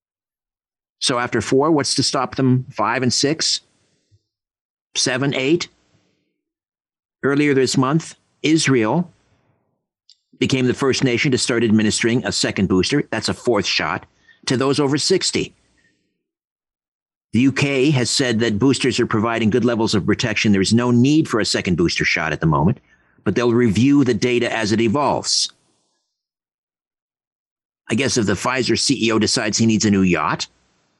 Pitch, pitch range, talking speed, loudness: 125 Hz, 110-135 Hz, 150 wpm, -18 LUFS